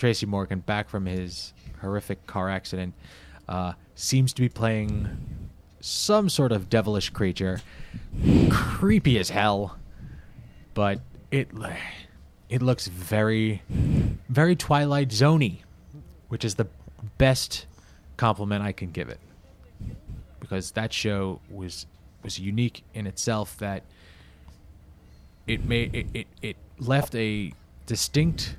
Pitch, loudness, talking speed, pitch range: 100 Hz, -26 LUFS, 115 wpm, 90-115 Hz